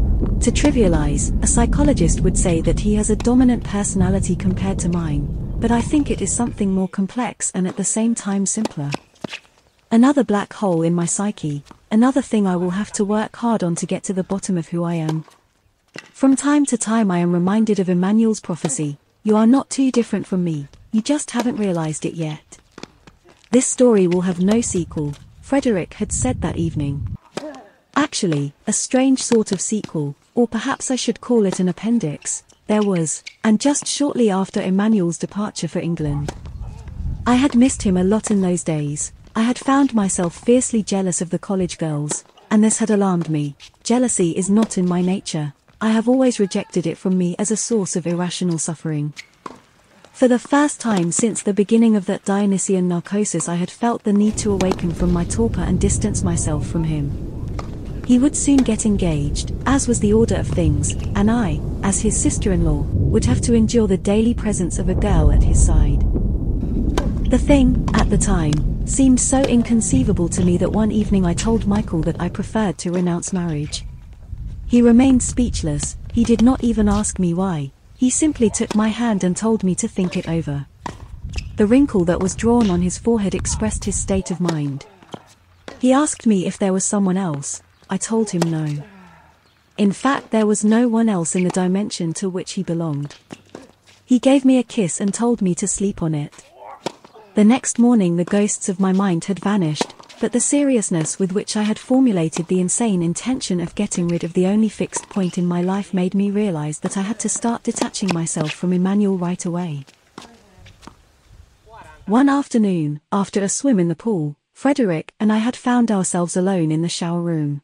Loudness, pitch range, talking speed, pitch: -19 LUFS, 170-225 Hz, 190 wpm, 195 Hz